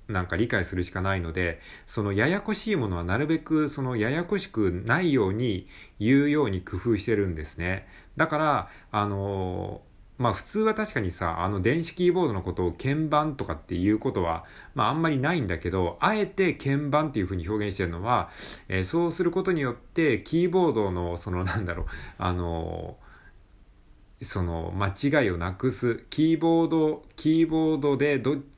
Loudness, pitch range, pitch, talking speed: -26 LUFS, 90-150 Hz, 105 Hz, 360 characters per minute